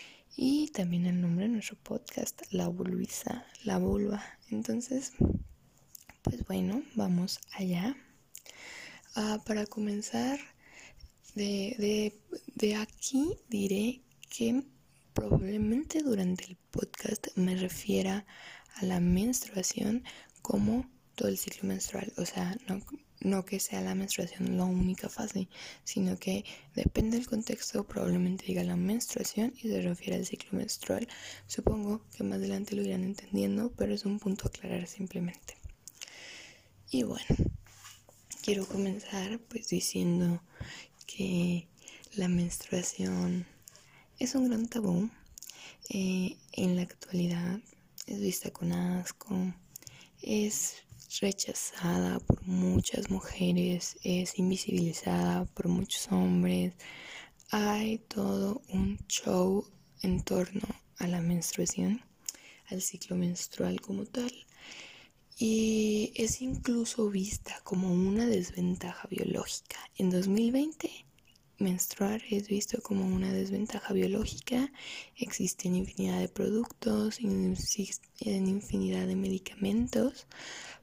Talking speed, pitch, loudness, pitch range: 110 wpm, 195 Hz, -33 LUFS, 180-220 Hz